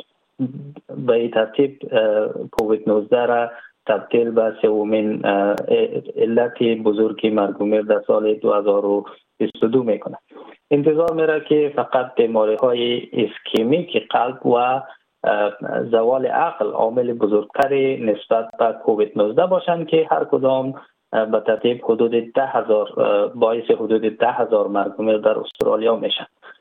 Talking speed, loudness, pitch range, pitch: 110 wpm, -19 LUFS, 110-145 Hz, 120 Hz